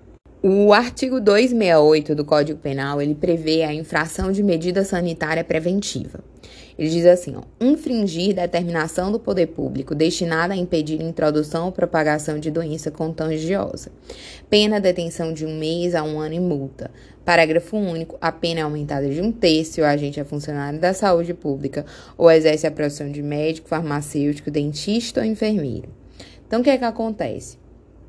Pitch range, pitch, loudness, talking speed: 150-180 Hz, 160 Hz, -20 LUFS, 165 wpm